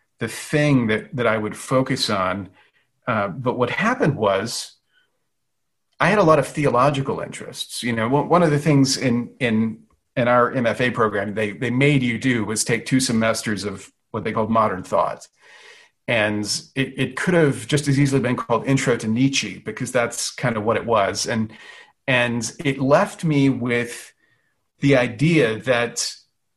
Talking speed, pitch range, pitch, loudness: 170 wpm, 110-140 Hz, 125 Hz, -20 LUFS